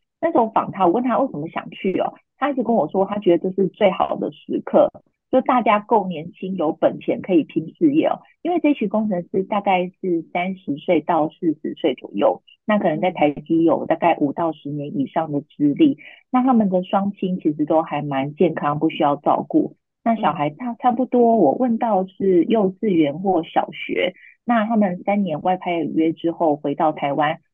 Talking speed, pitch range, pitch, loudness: 285 characters per minute, 160-230 Hz, 190 Hz, -20 LUFS